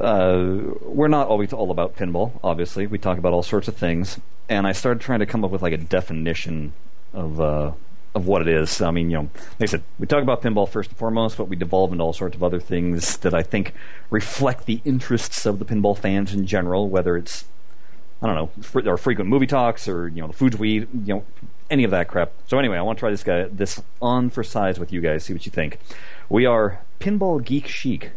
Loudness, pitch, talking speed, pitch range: -22 LUFS, 100 Hz, 245 wpm, 85-115 Hz